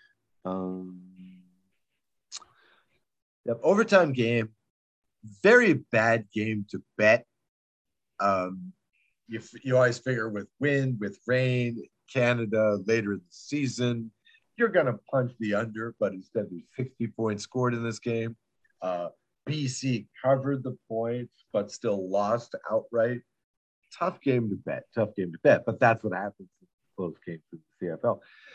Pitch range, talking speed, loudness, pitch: 105-125 Hz, 135 wpm, -28 LUFS, 115 Hz